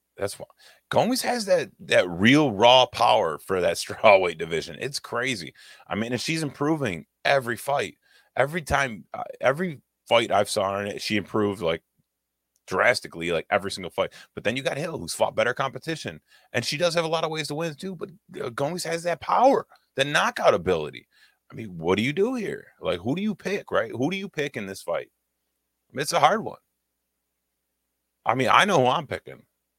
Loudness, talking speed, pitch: -24 LUFS, 200 wpm, 135 Hz